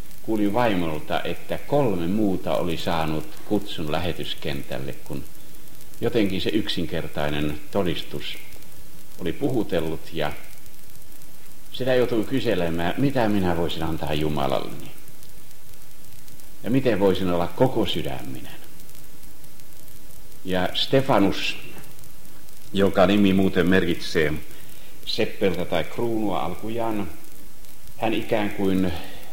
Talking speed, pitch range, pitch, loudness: 90 wpm, 80-105 Hz, 90 Hz, -24 LUFS